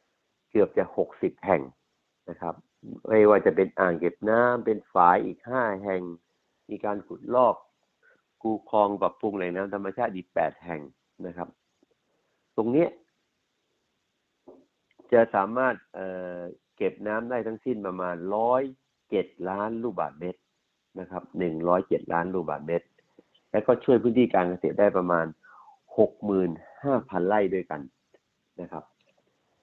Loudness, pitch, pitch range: -26 LUFS, 95 Hz, 90-110 Hz